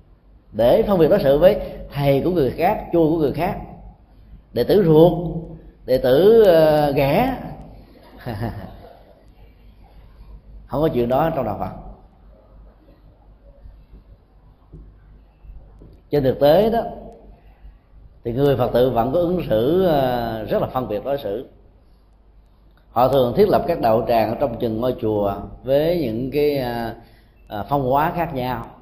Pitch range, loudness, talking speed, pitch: 105-160 Hz, -19 LUFS, 135 wpm, 130 Hz